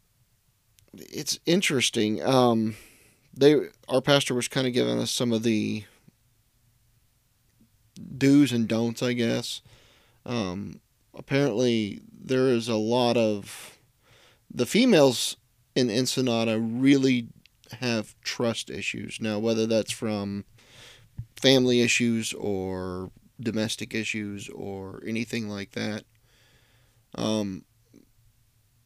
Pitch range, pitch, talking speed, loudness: 110-125 Hz, 115 Hz, 100 wpm, -25 LUFS